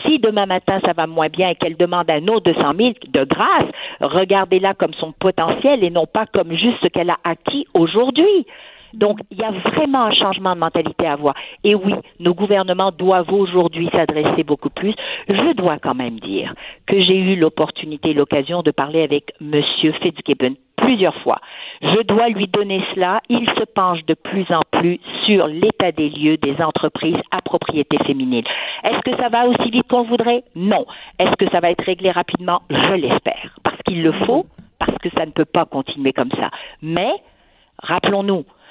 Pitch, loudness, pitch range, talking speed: 180 Hz, -17 LUFS, 160-210 Hz, 190 wpm